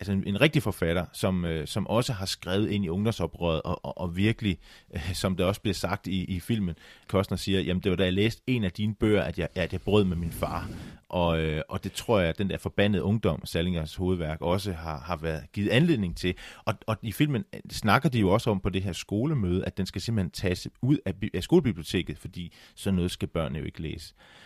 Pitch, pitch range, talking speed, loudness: 95 Hz, 85-105 Hz, 230 wpm, -28 LUFS